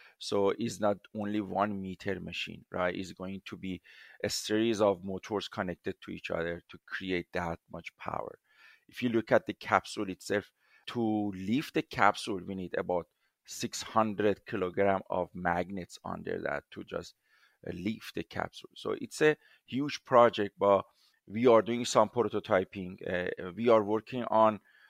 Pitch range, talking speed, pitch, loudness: 95-110 Hz, 160 wpm, 100 Hz, -32 LUFS